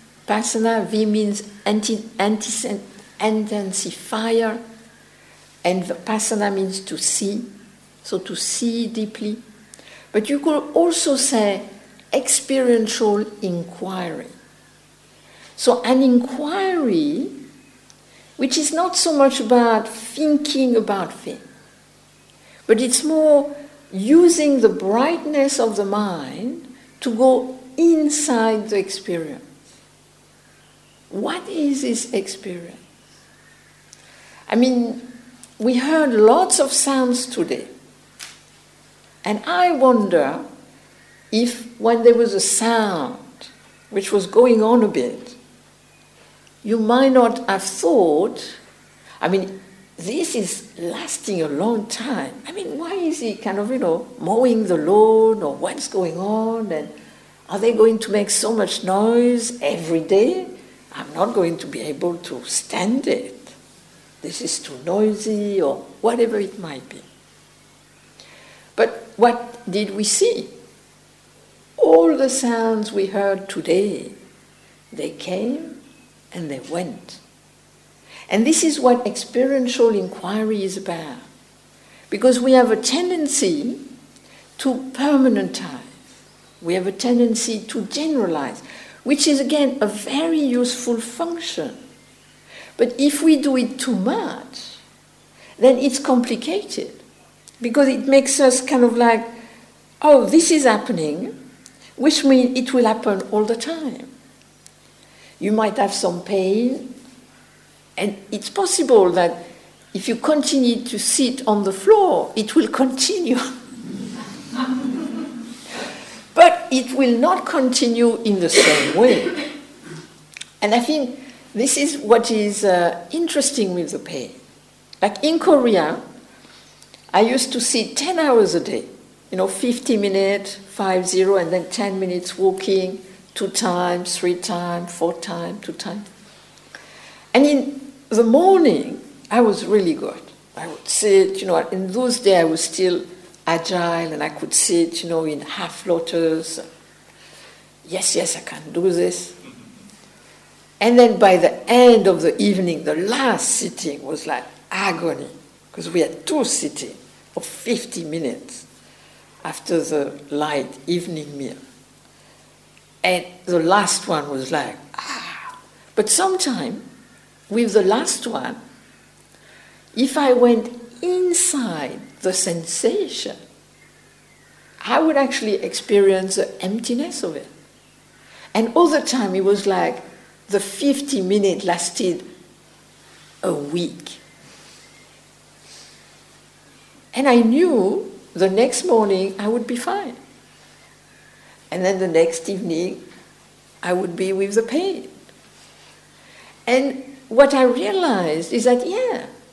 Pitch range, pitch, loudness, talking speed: 195-265 Hz, 230 Hz, -19 LUFS, 120 wpm